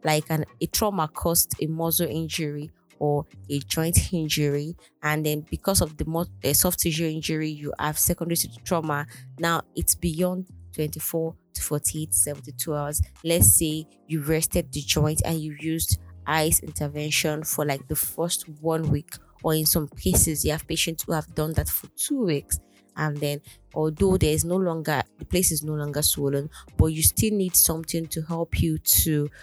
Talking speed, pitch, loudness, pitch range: 175 wpm, 155 Hz, -24 LUFS, 145-165 Hz